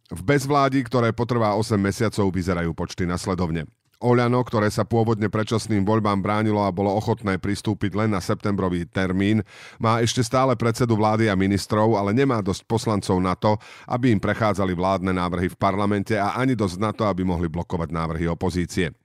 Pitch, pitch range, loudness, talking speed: 105 Hz, 95-115 Hz, -22 LUFS, 170 wpm